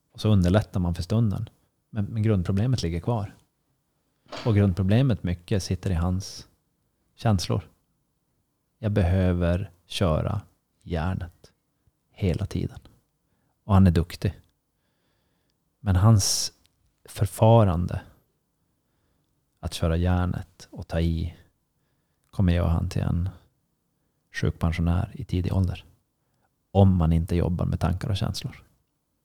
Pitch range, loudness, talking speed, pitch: 90-115 Hz, -25 LUFS, 110 wpm, 95 Hz